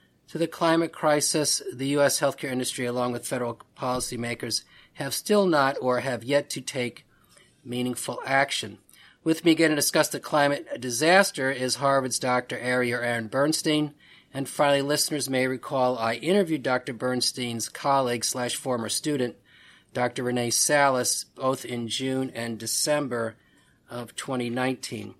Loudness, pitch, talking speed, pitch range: -25 LUFS, 130 Hz, 140 wpm, 125-145 Hz